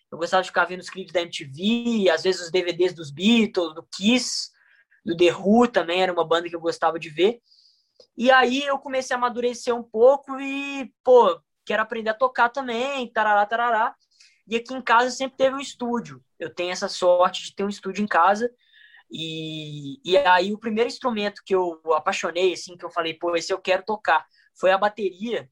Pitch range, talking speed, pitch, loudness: 175-240 Hz, 200 wpm, 195 Hz, -22 LUFS